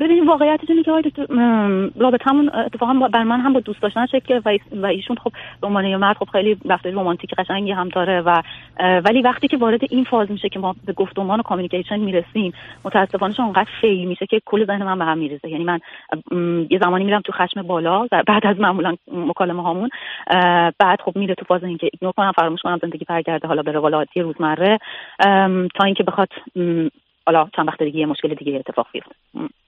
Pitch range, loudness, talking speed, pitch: 175-220 Hz, -18 LUFS, 205 wpm, 195 Hz